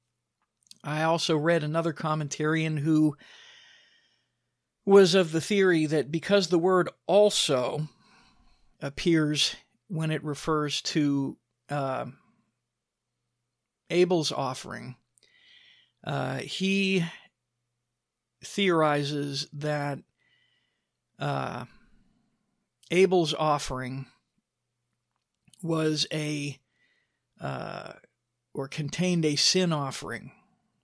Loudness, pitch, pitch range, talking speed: -26 LUFS, 155 Hz, 135-175 Hz, 75 wpm